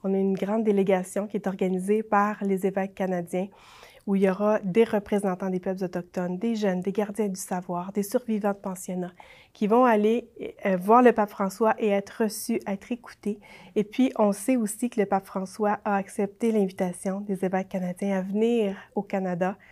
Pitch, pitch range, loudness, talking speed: 200 Hz, 190-215 Hz, -26 LUFS, 190 wpm